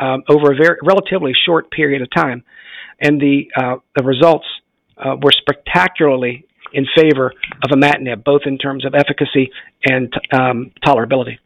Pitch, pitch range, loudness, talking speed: 140 Hz, 135-150 Hz, -14 LUFS, 155 wpm